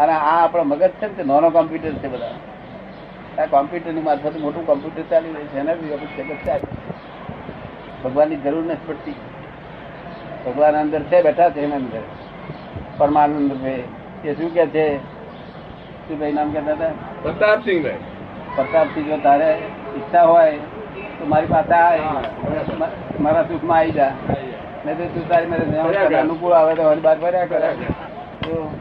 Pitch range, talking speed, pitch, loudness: 145-165 Hz, 100 wpm, 155 Hz, -19 LUFS